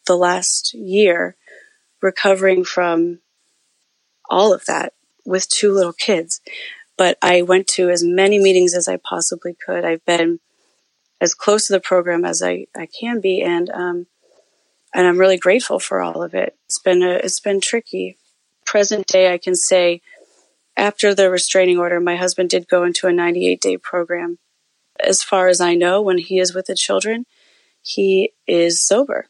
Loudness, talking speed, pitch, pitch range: -16 LUFS, 170 wpm, 185 Hz, 175-205 Hz